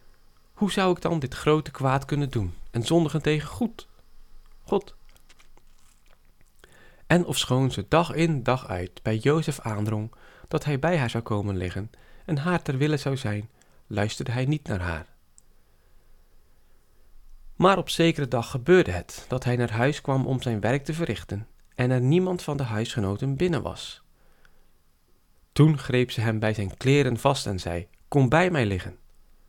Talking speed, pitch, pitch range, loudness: 165 wpm, 125 Hz, 95-150 Hz, -25 LUFS